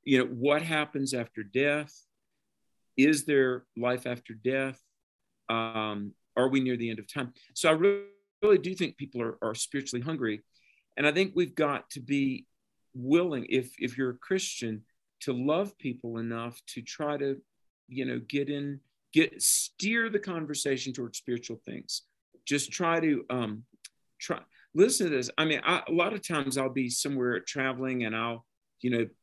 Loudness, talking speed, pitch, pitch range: -30 LUFS, 170 wpm, 135 Hz, 120-150 Hz